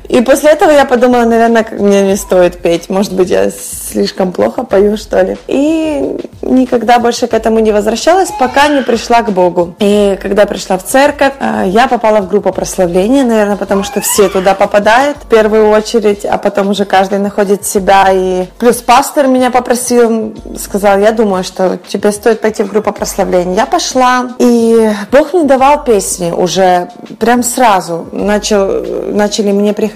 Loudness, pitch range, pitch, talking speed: -10 LUFS, 195-245 Hz, 215 Hz, 170 wpm